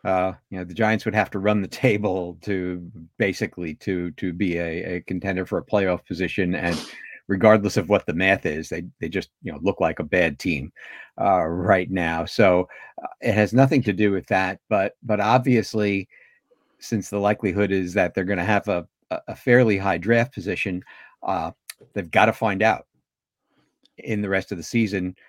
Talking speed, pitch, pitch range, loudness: 195 wpm, 100 Hz, 90-105 Hz, -23 LUFS